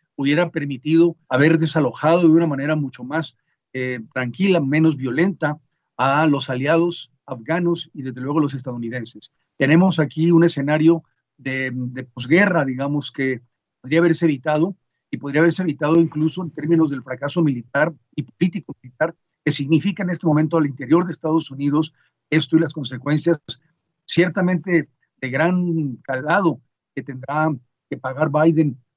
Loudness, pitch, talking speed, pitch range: -20 LUFS, 155 Hz, 145 wpm, 135-165 Hz